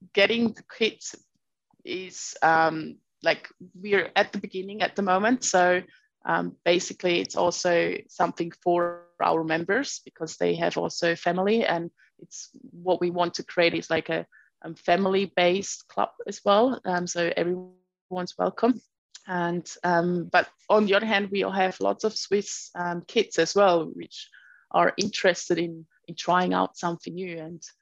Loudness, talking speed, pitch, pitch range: -25 LUFS, 160 wpm, 180 Hz, 170-200 Hz